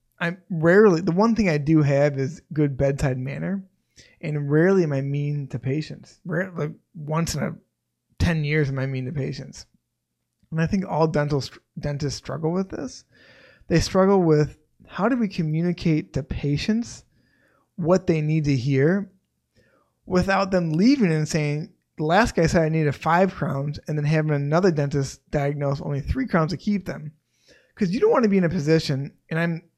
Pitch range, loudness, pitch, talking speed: 145-185 Hz, -23 LUFS, 160 Hz, 180 wpm